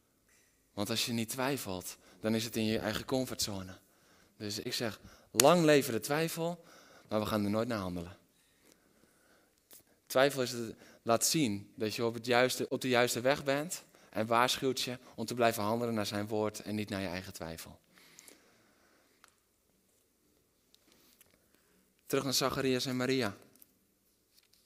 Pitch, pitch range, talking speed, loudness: 115 Hz, 105-130 Hz, 150 wpm, -33 LUFS